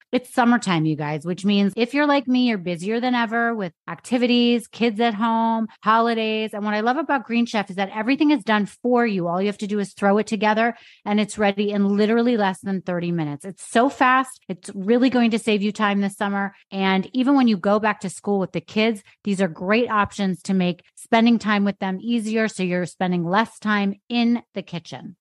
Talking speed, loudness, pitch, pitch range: 225 wpm, -21 LUFS, 210 Hz, 195-235 Hz